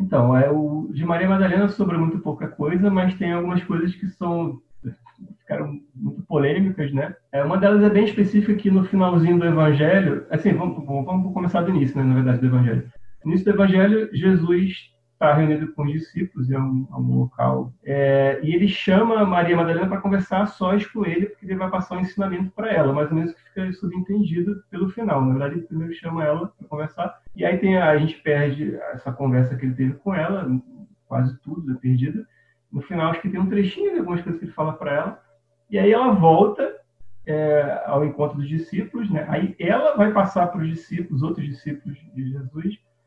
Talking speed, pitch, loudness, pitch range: 205 wpm, 170 Hz, -21 LUFS, 145-190 Hz